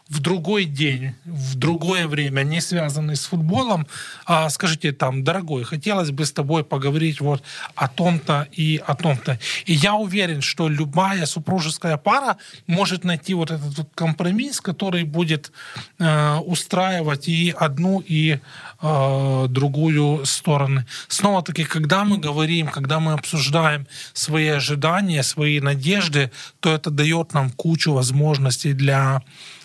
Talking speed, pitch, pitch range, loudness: 130 wpm, 155 Hz, 145-170 Hz, -20 LUFS